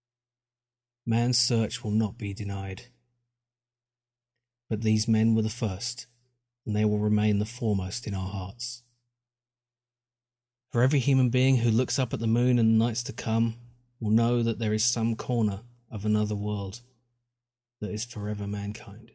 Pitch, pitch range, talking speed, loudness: 120 Hz, 110-120 Hz, 155 wpm, -27 LUFS